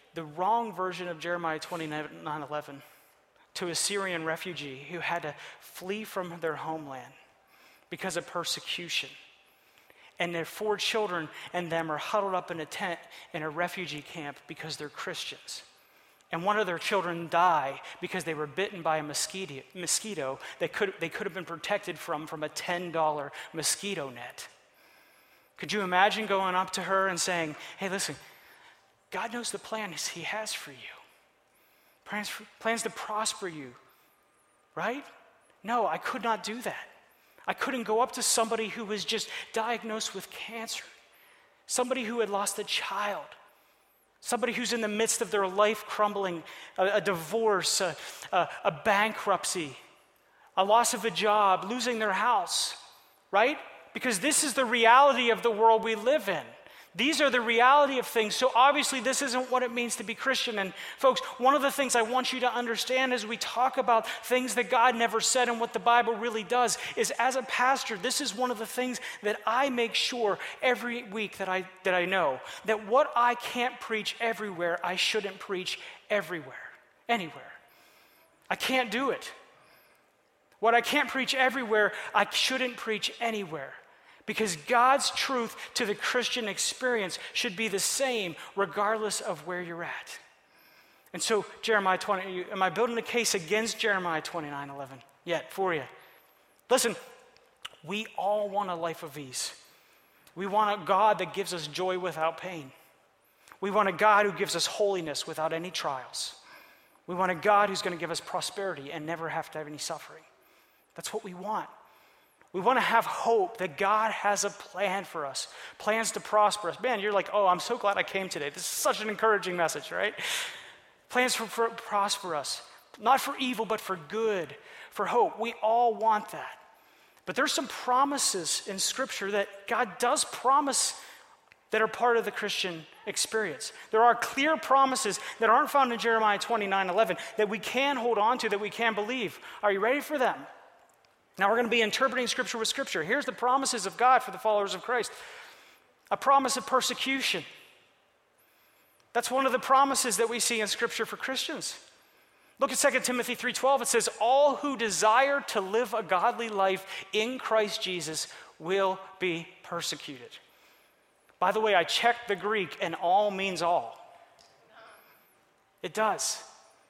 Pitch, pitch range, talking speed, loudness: 215 Hz, 185-240 Hz, 175 wpm, -28 LUFS